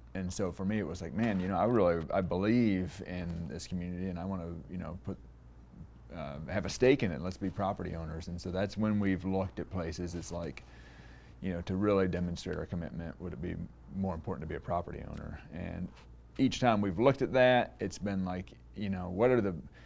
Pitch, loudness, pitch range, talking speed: 90 Hz, -33 LUFS, 85-100 Hz, 230 wpm